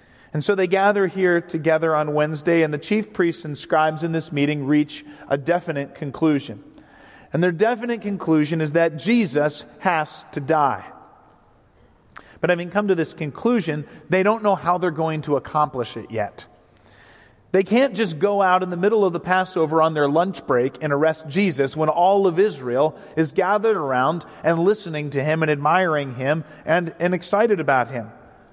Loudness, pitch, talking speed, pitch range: -21 LUFS, 160 Hz, 175 wpm, 150-190 Hz